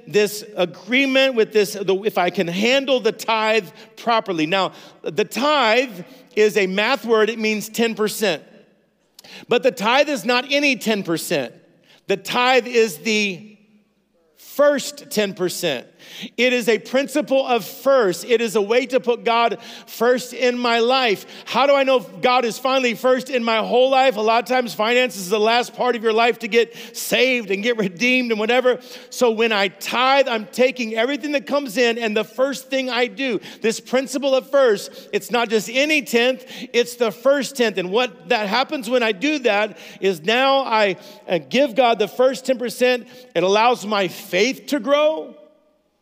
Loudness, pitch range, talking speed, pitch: -19 LUFS, 215-255 Hz, 175 wpm, 235 Hz